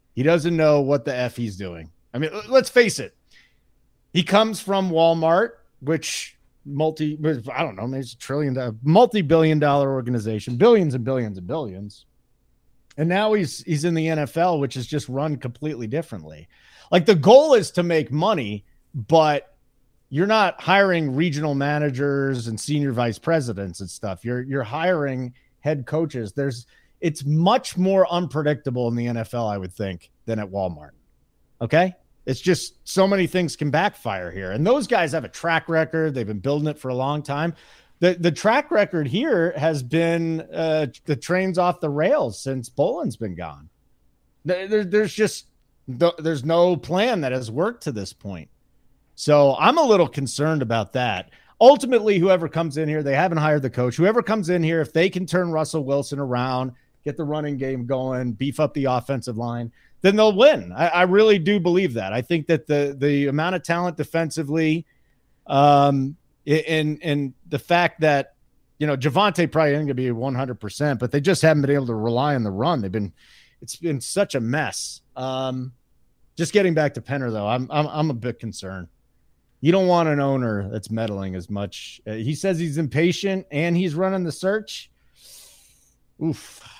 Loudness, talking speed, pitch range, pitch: -21 LUFS, 180 wpm, 125-170 Hz, 150 Hz